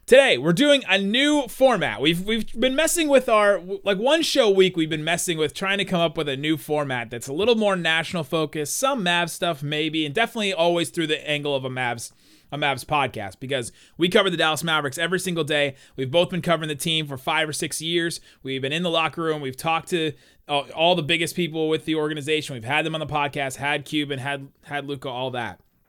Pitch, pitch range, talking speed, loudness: 160 Hz, 145-180 Hz, 230 wpm, -22 LUFS